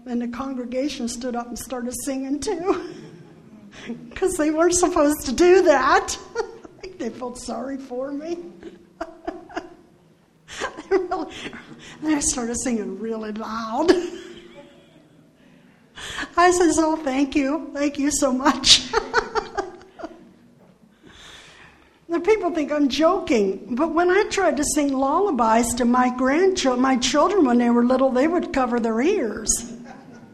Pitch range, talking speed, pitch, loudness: 245-345 Hz, 125 wpm, 290 Hz, -21 LUFS